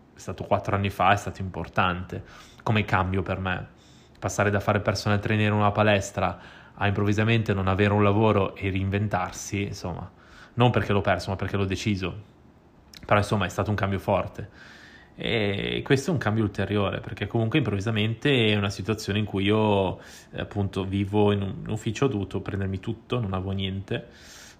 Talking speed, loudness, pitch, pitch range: 175 wpm, -26 LUFS, 100 Hz, 95-105 Hz